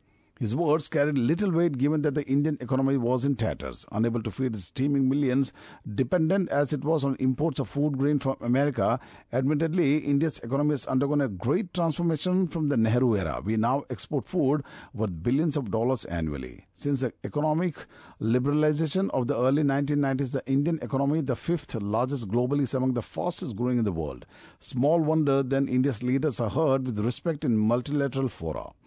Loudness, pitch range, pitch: -27 LUFS, 120-150 Hz, 135 Hz